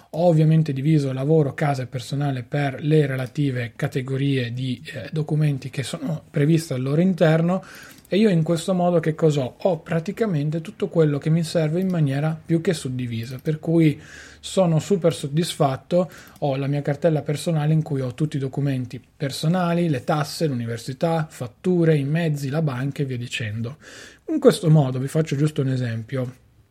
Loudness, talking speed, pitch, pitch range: -22 LUFS, 170 wpm, 150 Hz, 135-165 Hz